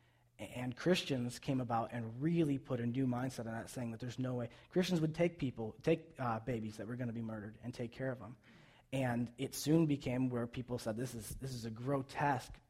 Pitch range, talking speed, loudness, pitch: 120-135 Hz, 225 wpm, -39 LUFS, 125 Hz